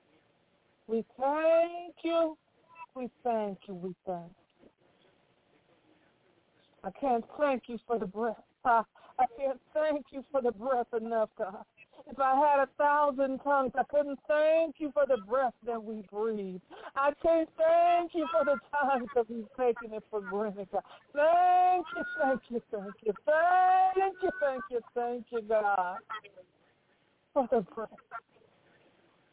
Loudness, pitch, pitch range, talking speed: -30 LUFS, 265 Hz, 225-310 Hz, 145 wpm